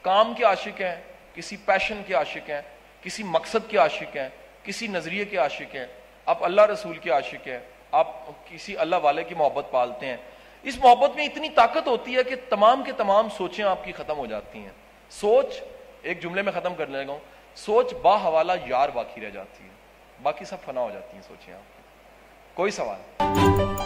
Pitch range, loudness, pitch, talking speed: 155-225 Hz, -24 LUFS, 185 Hz, 195 wpm